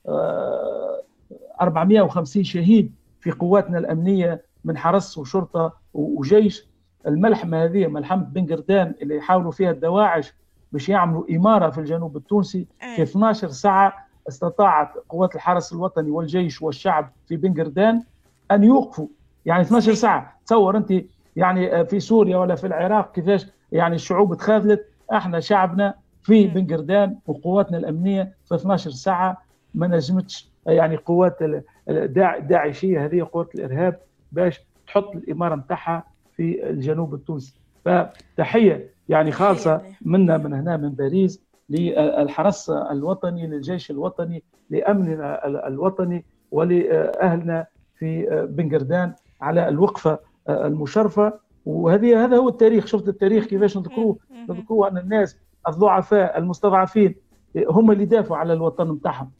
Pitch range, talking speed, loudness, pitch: 160-200 Hz, 115 wpm, -20 LUFS, 180 Hz